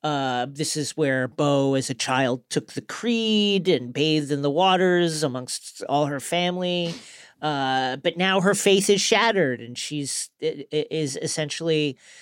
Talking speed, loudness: 160 wpm, -23 LUFS